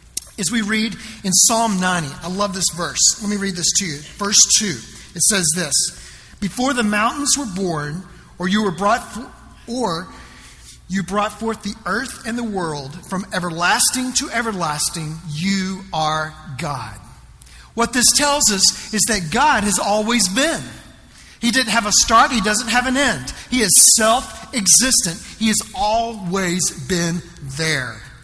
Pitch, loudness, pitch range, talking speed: 200 Hz, -16 LUFS, 175-230 Hz, 160 wpm